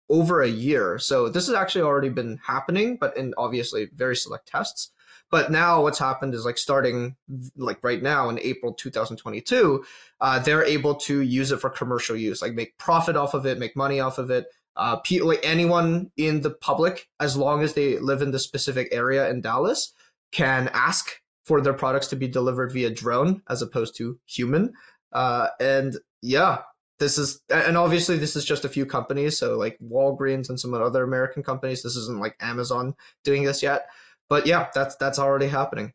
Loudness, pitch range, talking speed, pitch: -24 LUFS, 125-150 Hz, 190 wpm, 135 Hz